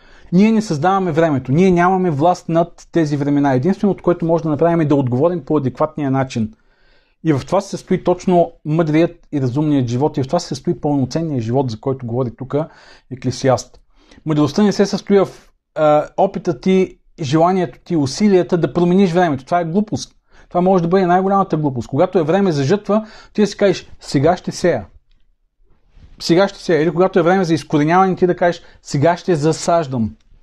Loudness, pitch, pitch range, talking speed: -17 LUFS, 170 Hz, 145-180 Hz, 185 wpm